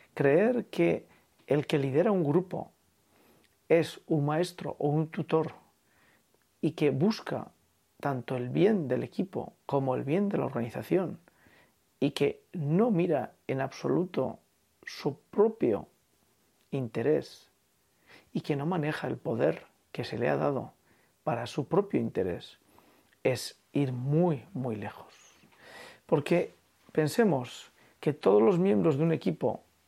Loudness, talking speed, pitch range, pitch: -30 LUFS, 130 wpm, 140-175 Hz, 155 Hz